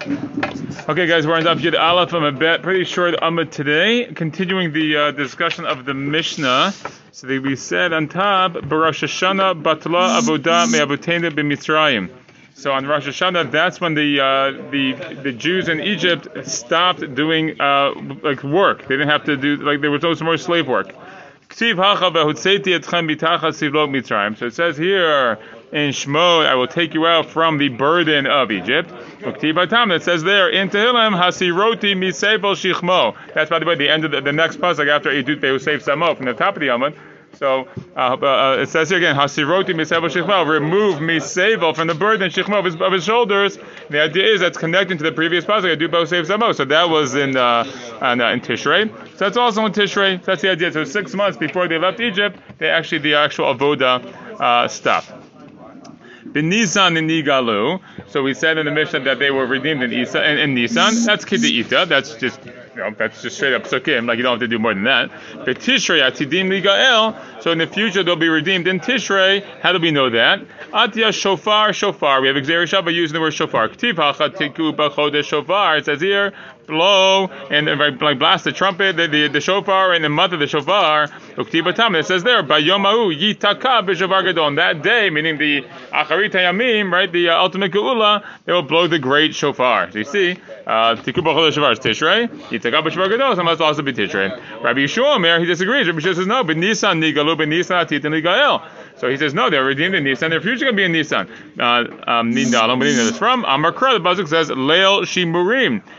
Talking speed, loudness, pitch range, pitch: 190 wpm, -16 LUFS, 150-190 Hz, 165 Hz